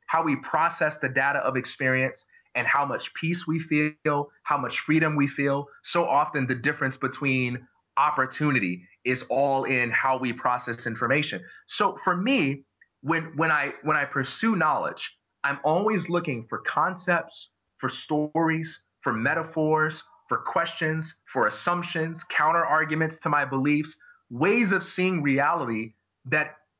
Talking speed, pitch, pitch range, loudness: 140 wpm, 150 Hz, 130-160 Hz, -25 LUFS